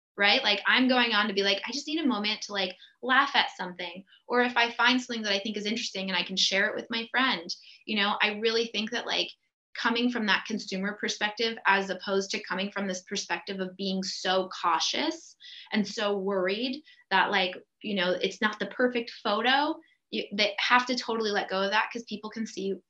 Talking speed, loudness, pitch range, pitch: 220 wpm, -27 LUFS, 195-235 Hz, 210 Hz